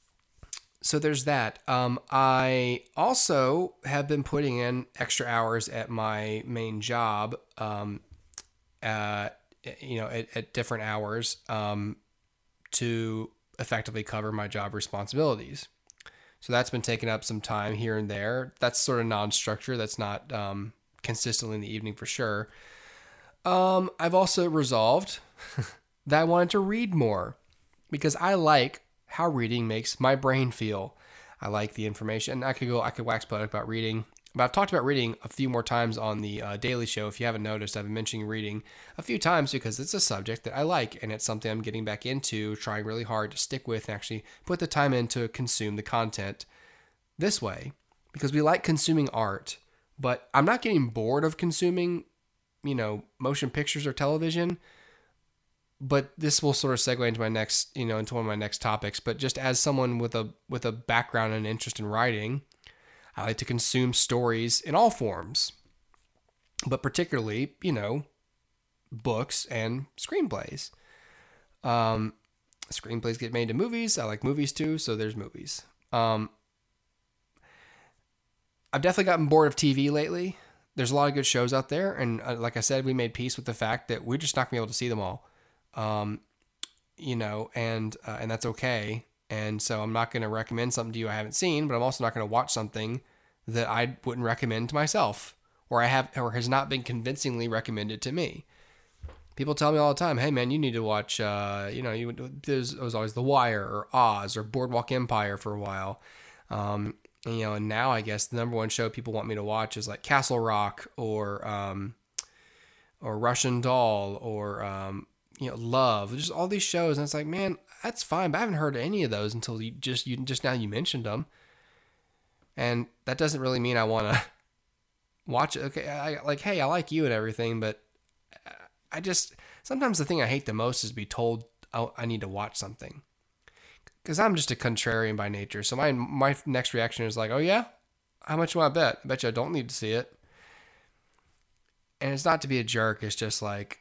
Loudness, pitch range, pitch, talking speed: -29 LUFS, 110-135 Hz, 120 Hz, 195 wpm